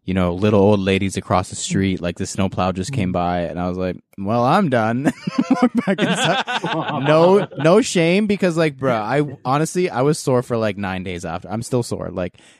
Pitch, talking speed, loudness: 110 Hz, 195 wpm, -19 LUFS